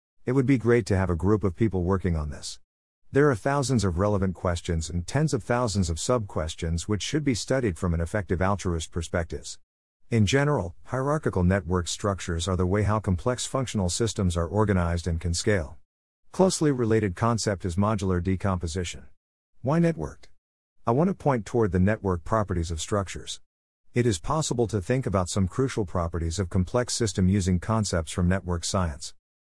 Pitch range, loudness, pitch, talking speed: 85-115 Hz, -26 LUFS, 95 Hz, 175 wpm